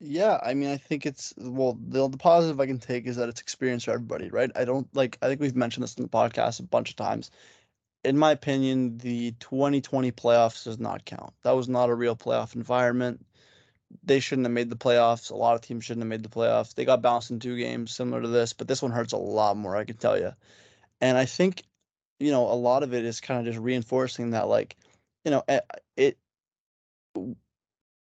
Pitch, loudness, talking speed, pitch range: 125 Hz, -26 LUFS, 225 wpm, 120-135 Hz